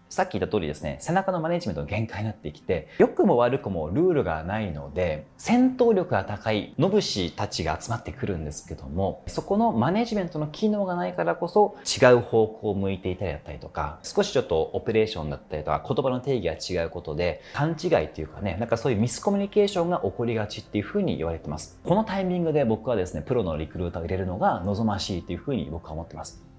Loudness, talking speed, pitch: -26 LUFS, 500 characters per minute, 105 Hz